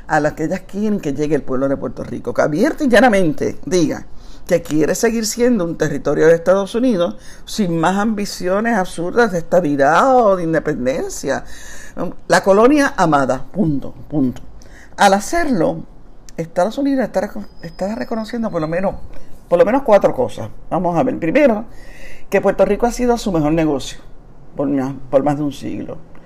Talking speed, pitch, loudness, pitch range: 170 wpm, 180 Hz, -17 LUFS, 150-225 Hz